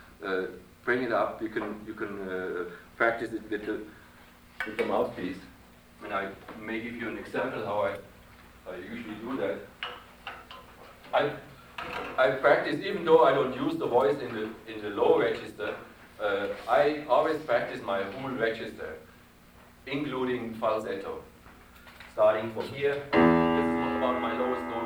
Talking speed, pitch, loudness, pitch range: 155 wpm, 110 Hz, -29 LUFS, 85-135 Hz